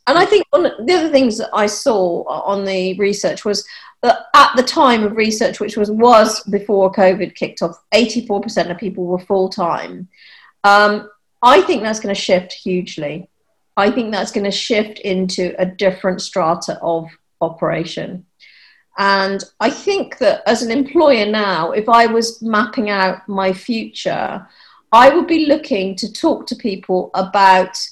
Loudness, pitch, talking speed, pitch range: -15 LUFS, 205 Hz, 165 wpm, 190-235 Hz